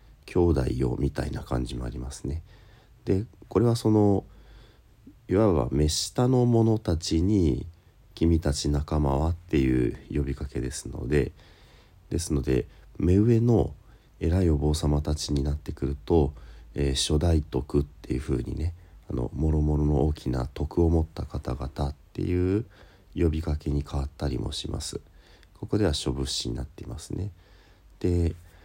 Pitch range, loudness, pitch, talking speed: 70-95 Hz, -27 LUFS, 80 Hz, 280 characters per minute